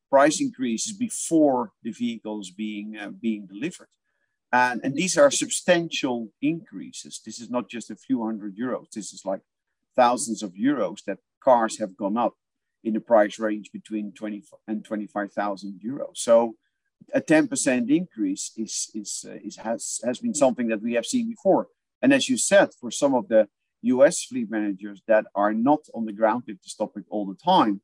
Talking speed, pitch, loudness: 180 wpm, 120 Hz, -24 LUFS